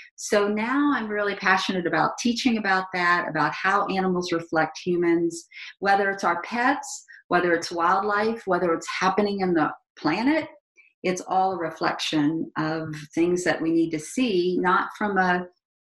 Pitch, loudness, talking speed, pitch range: 185 Hz, -24 LUFS, 155 wpm, 170-210 Hz